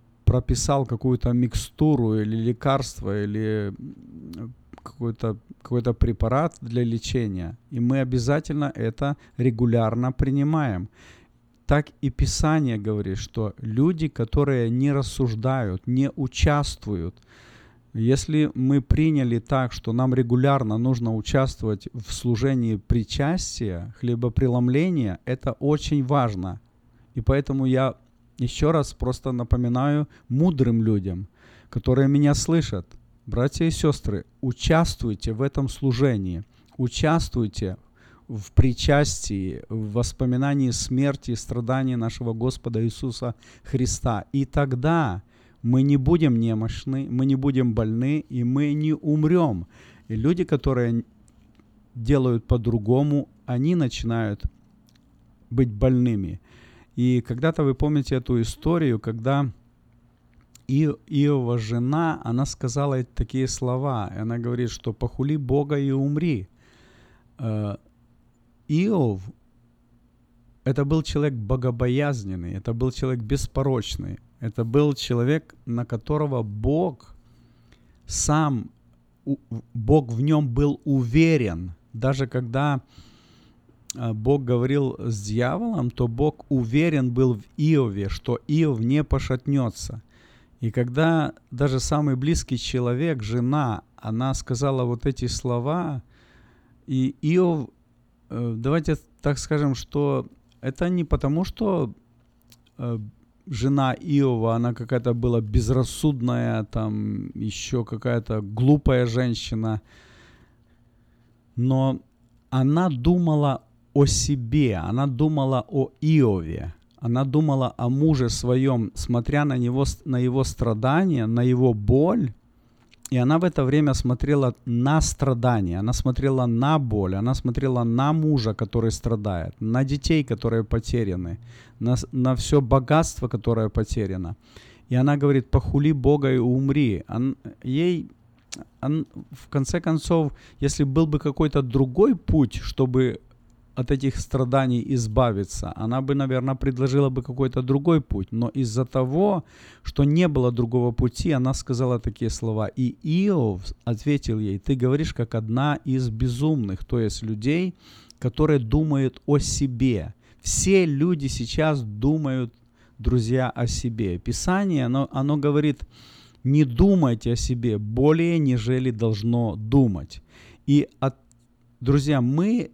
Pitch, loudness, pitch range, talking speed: 125 Hz, -23 LUFS, 115-140 Hz, 115 wpm